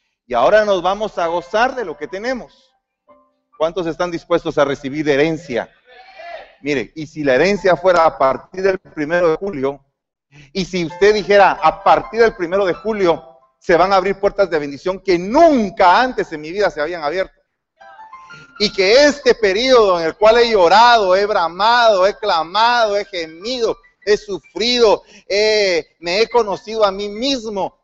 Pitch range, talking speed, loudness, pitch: 160-220 Hz, 170 wpm, -15 LUFS, 190 Hz